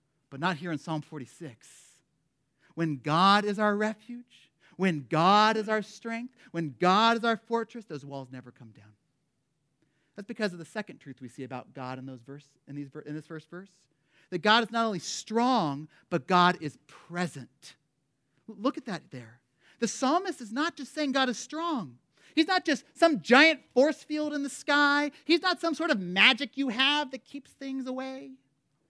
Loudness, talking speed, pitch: -27 LUFS, 185 wpm, 185 Hz